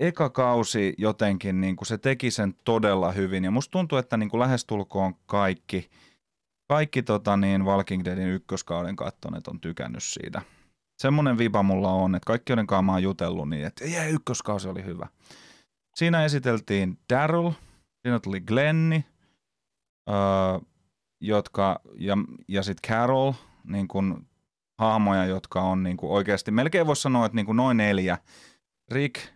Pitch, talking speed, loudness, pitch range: 105 Hz, 145 wpm, -26 LUFS, 95-125 Hz